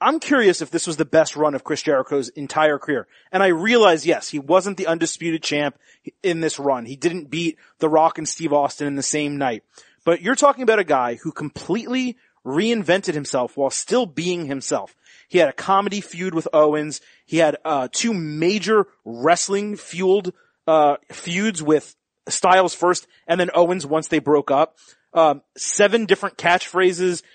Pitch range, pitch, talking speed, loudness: 150-190 Hz, 165 Hz, 180 wpm, -20 LUFS